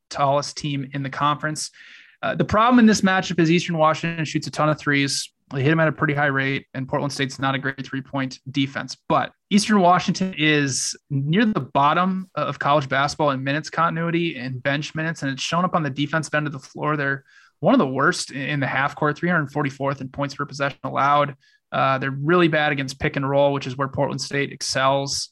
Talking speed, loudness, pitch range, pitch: 220 wpm, -21 LUFS, 140-160 Hz, 145 Hz